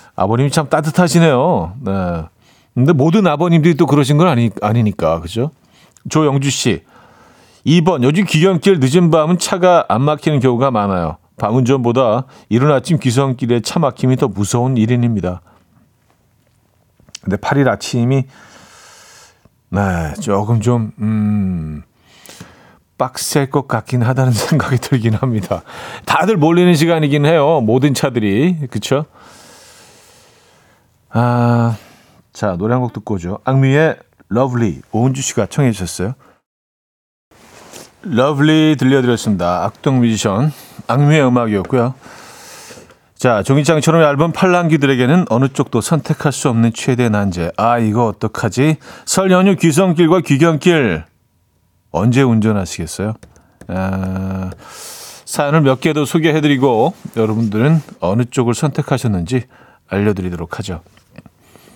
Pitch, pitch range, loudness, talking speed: 125 Hz, 105-150 Hz, -15 LUFS, 270 characters per minute